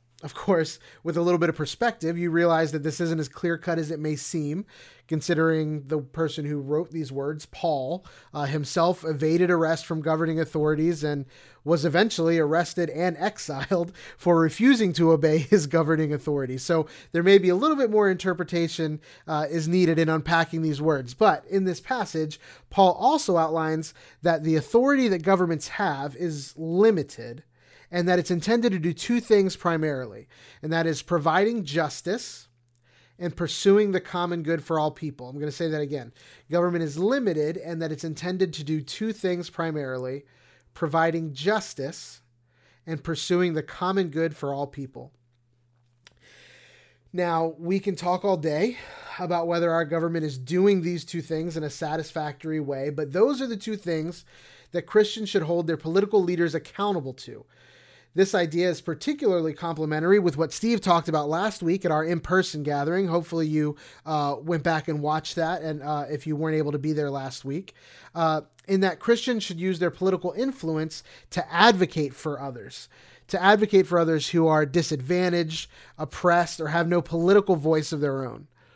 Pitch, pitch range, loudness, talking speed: 165 Hz, 150-180 Hz, -25 LUFS, 170 wpm